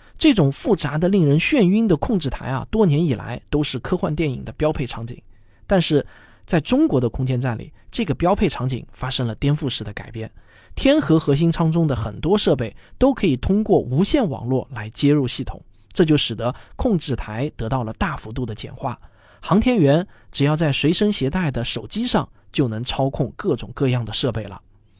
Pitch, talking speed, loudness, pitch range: 135 Hz, 290 characters per minute, -20 LUFS, 115-165 Hz